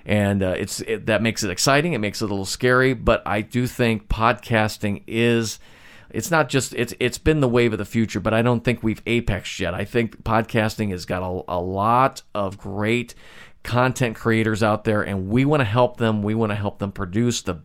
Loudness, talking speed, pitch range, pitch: -21 LUFS, 220 wpm, 100-120 Hz, 110 Hz